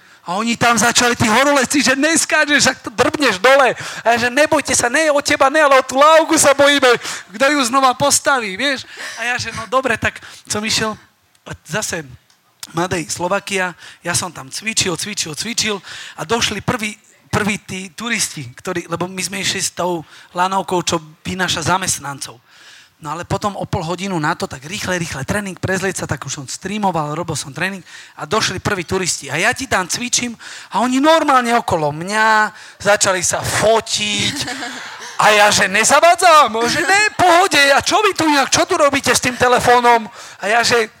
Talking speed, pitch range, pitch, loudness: 185 wpm, 180-265 Hz, 215 Hz, -15 LUFS